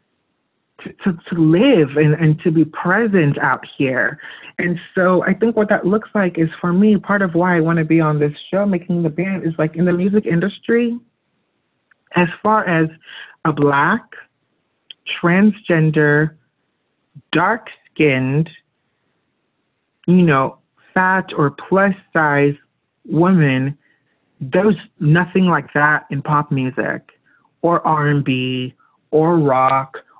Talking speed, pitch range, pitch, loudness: 130 wpm, 150-190 Hz, 165 Hz, -16 LUFS